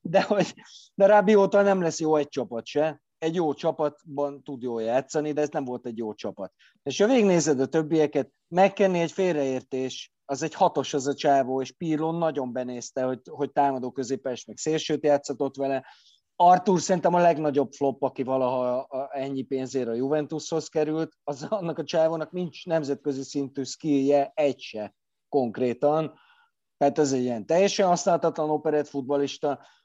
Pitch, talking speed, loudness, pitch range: 145 Hz, 160 wpm, -25 LUFS, 135-160 Hz